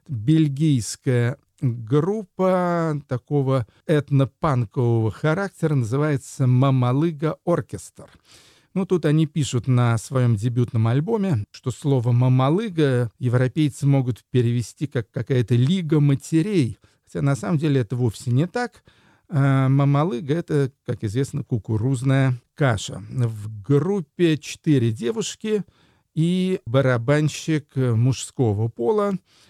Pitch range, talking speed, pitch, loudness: 120-155 Hz, 100 wpm, 135 Hz, -22 LUFS